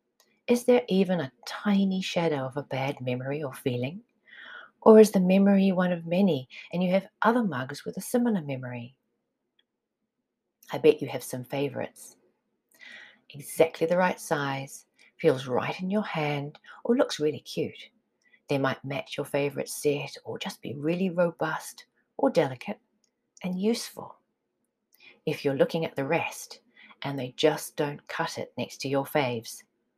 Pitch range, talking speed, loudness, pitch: 140-195 Hz, 155 wpm, -27 LUFS, 165 Hz